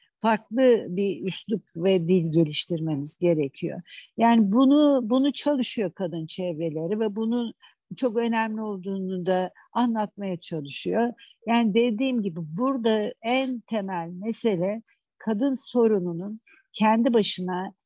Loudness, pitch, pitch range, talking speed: -25 LUFS, 215 Hz, 180-235 Hz, 110 wpm